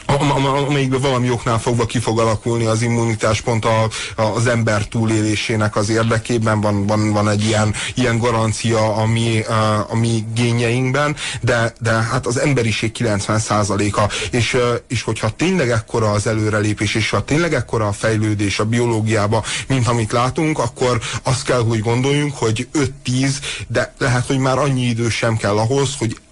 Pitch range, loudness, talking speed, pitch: 110-125 Hz, -18 LUFS, 155 wpm, 115 Hz